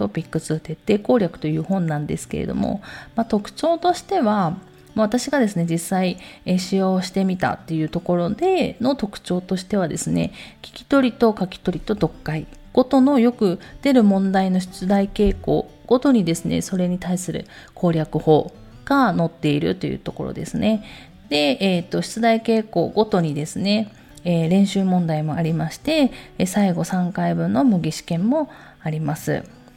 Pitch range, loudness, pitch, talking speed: 165-225 Hz, -21 LUFS, 185 Hz, 315 characters per minute